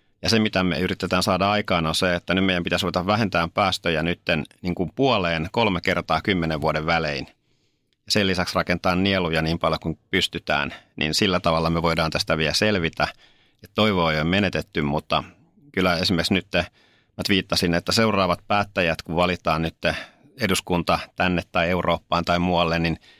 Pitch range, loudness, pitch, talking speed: 80-95 Hz, -22 LUFS, 90 Hz, 165 wpm